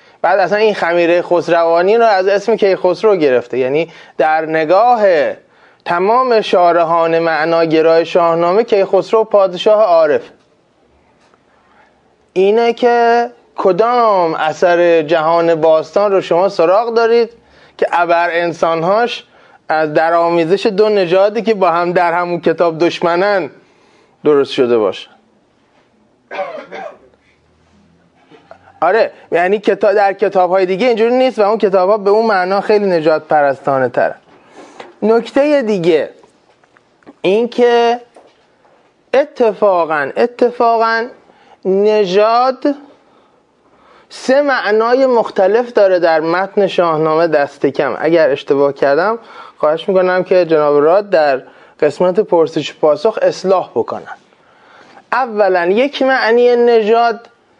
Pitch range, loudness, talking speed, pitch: 170-230 Hz, -13 LUFS, 105 wpm, 200 Hz